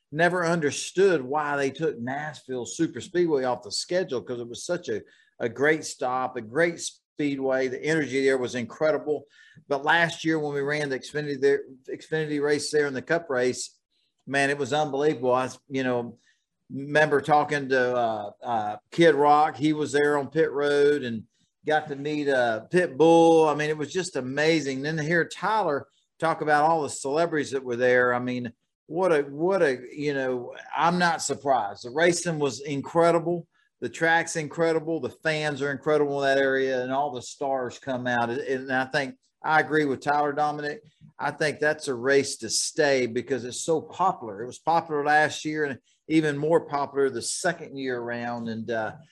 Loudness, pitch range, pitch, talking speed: -25 LUFS, 130-155 Hz, 145 Hz, 190 wpm